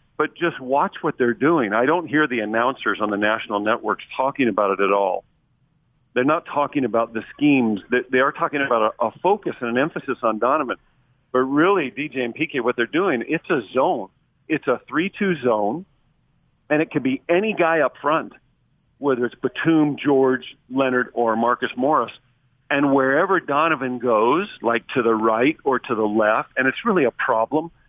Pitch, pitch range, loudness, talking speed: 130 Hz, 120-150 Hz, -21 LUFS, 185 wpm